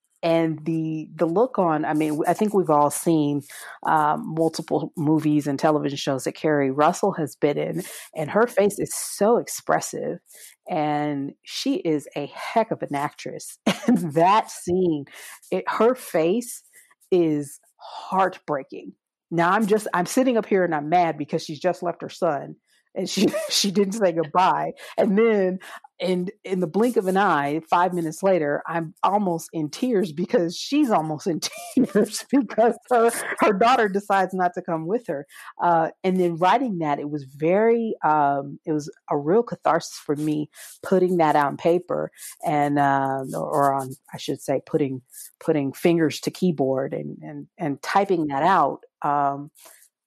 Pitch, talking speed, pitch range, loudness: 170 Hz, 160 wpm, 150-195 Hz, -23 LUFS